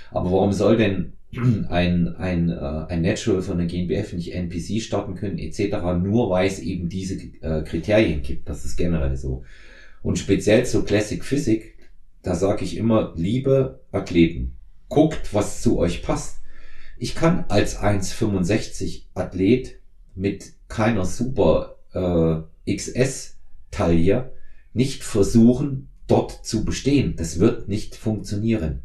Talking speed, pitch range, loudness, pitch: 125 wpm, 85-110 Hz, -22 LUFS, 95 Hz